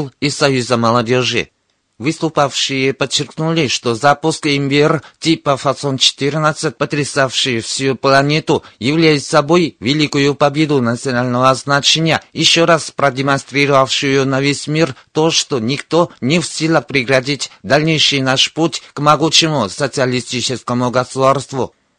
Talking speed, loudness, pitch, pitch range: 105 wpm, -14 LUFS, 140 Hz, 130-155 Hz